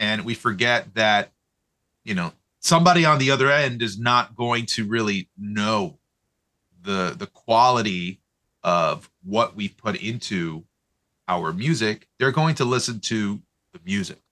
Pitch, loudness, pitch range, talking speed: 115 Hz, -22 LUFS, 105-135 Hz, 140 wpm